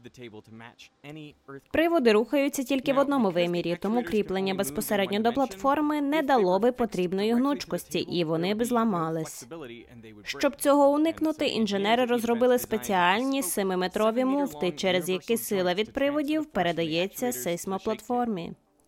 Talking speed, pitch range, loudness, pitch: 110 wpm, 175-270 Hz, -26 LUFS, 215 Hz